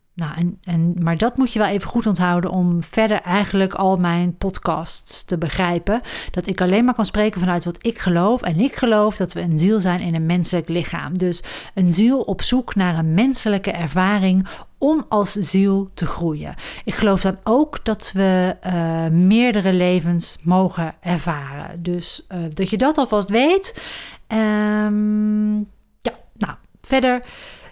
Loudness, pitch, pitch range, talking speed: -19 LUFS, 190 Hz, 175-210 Hz, 165 wpm